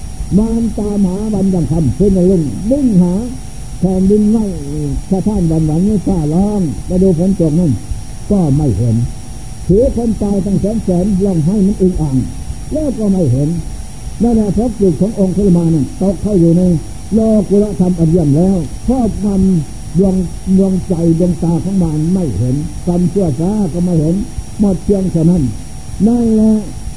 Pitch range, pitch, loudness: 160-200 Hz, 185 Hz, -13 LUFS